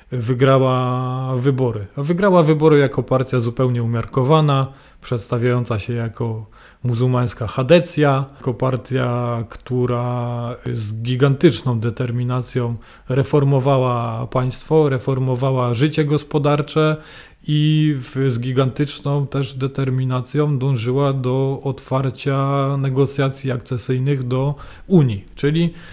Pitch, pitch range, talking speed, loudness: 130 Hz, 125-140 Hz, 85 wpm, -19 LUFS